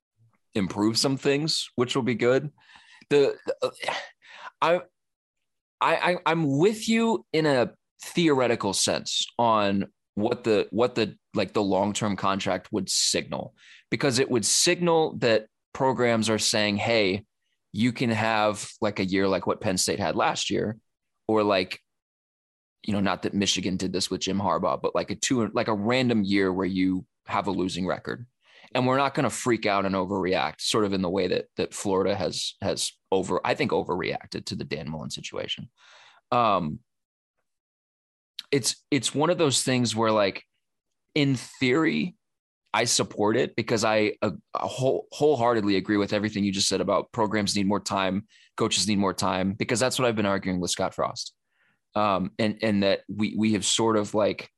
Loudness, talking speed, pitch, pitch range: -25 LUFS, 175 wpm, 110 Hz, 100-130 Hz